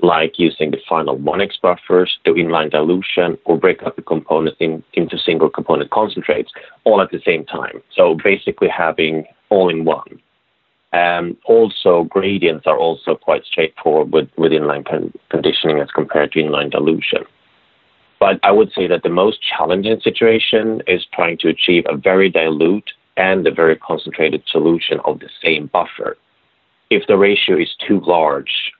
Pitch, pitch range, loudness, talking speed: 90 Hz, 80-110 Hz, -15 LUFS, 165 wpm